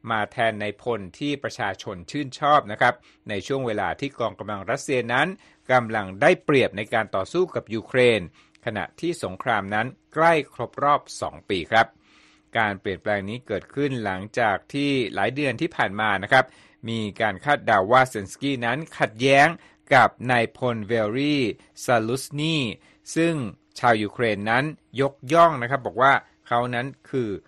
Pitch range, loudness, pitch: 110-140 Hz, -23 LUFS, 125 Hz